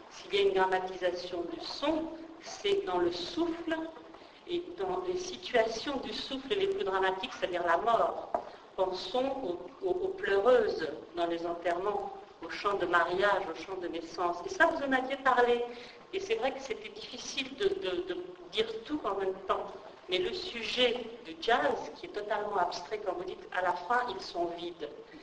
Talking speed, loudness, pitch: 185 wpm, -32 LUFS, 245 Hz